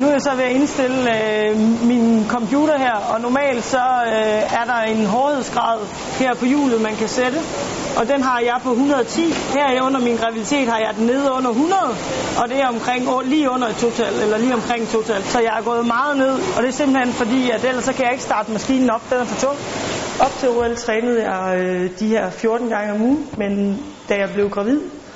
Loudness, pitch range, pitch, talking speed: -18 LUFS, 225-265 Hz, 245 Hz, 230 wpm